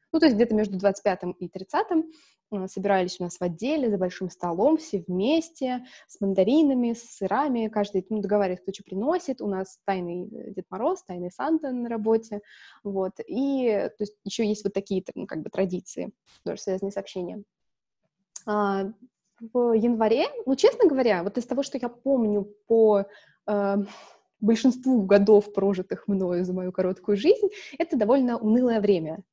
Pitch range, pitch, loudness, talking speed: 190-250 Hz, 210 Hz, -25 LUFS, 160 wpm